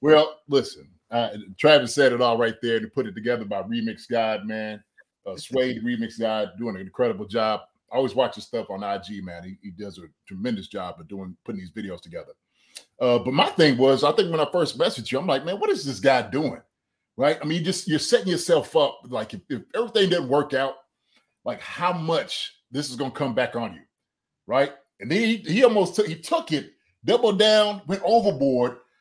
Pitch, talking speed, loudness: 145 Hz, 215 wpm, -23 LUFS